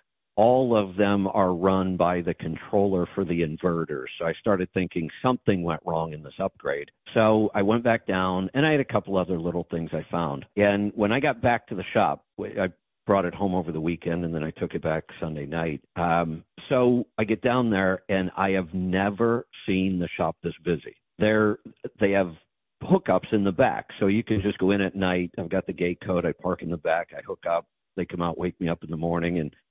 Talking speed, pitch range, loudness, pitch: 225 wpm, 85-105 Hz, -26 LUFS, 95 Hz